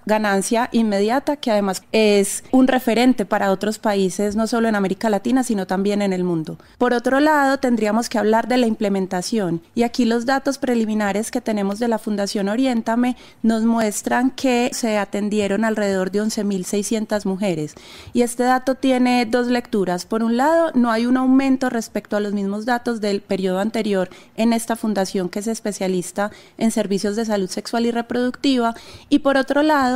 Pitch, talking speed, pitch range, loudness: 225 Hz, 175 wpm, 205-245 Hz, -20 LUFS